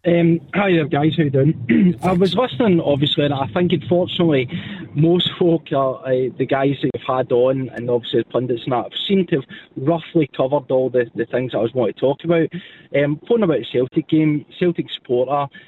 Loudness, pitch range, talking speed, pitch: -19 LUFS, 130-170 Hz, 215 wpm, 150 Hz